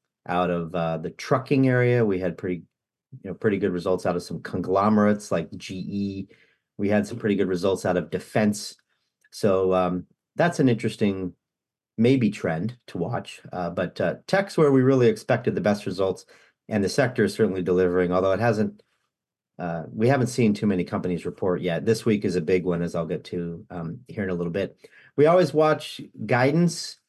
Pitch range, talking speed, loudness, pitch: 90-120 Hz, 195 wpm, -24 LUFS, 100 Hz